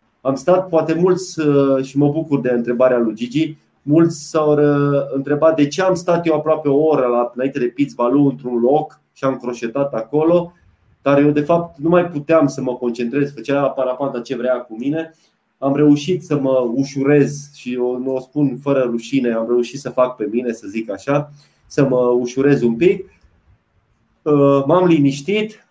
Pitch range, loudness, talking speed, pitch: 125-155 Hz, -17 LUFS, 180 wpm, 140 Hz